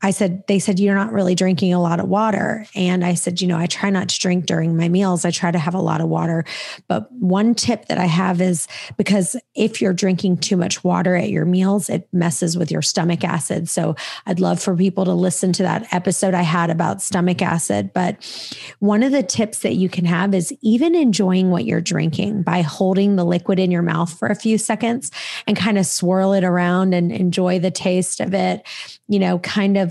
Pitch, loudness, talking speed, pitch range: 185 Hz, -18 LUFS, 225 wpm, 175-200 Hz